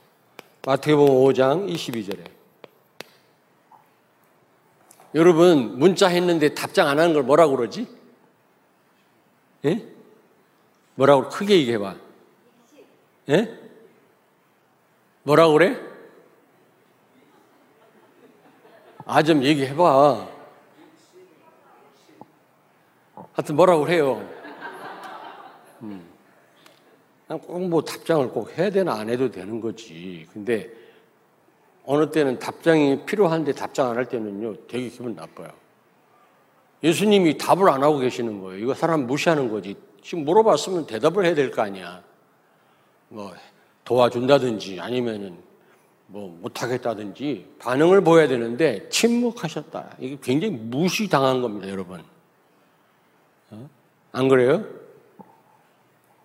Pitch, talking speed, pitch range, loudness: 145 Hz, 210 characters per minute, 120-170 Hz, -21 LUFS